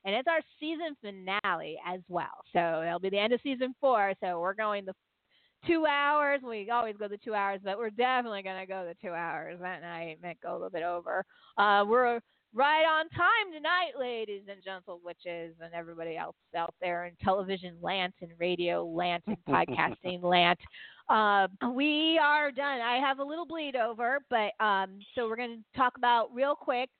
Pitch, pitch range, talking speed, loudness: 205 Hz, 175-255 Hz, 195 wpm, -30 LUFS